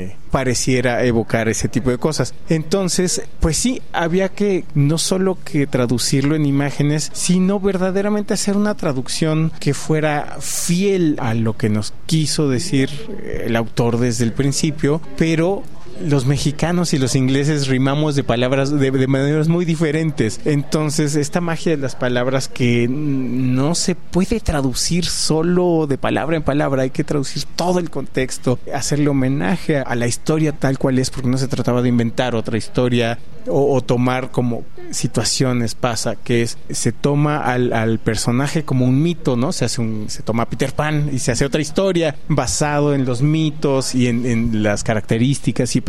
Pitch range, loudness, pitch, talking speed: 125-160 Hz, -18 LUFS, 140 Hz, 165 wpm